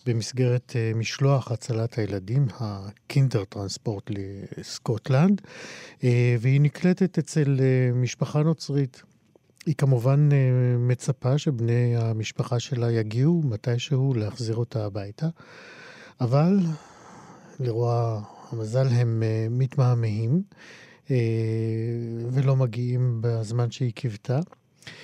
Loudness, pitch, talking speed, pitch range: -25 LUFS, 125 Hz, 80 wpm, 115-140 Hz